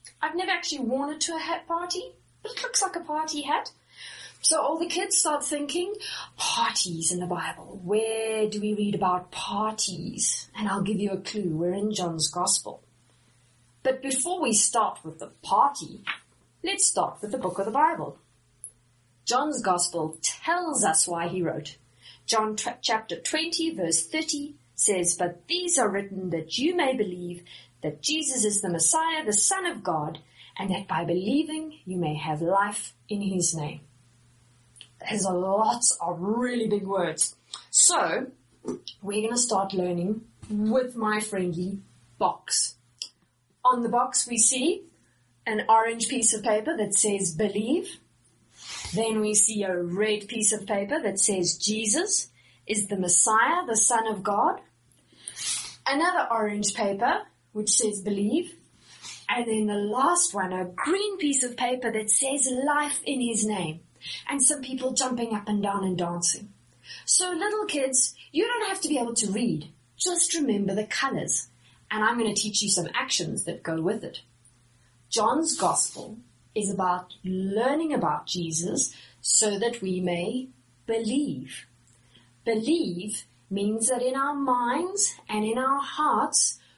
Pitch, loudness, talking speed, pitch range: 210 Hz, -25 LUFS, 155 wpm, 180-265 Hz